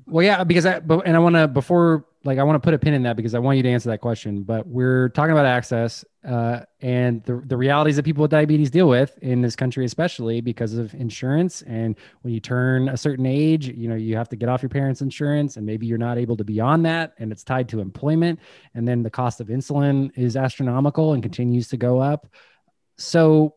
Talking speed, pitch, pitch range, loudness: 240 wpm, 130 Hz, 120-150 Hz, -21 LUFS